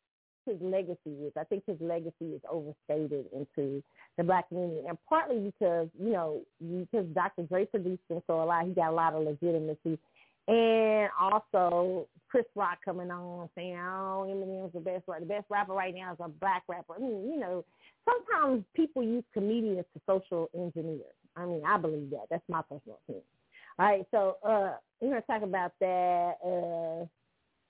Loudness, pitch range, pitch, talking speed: -32 LUFS, 165-205 Hz, 180 Hz, 180 wpm